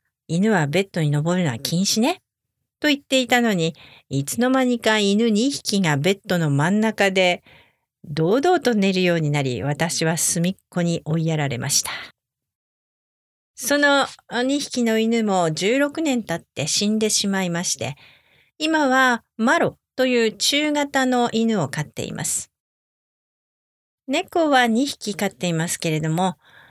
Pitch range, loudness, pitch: 165-245 Hz, -20 LUFS, 200 Hz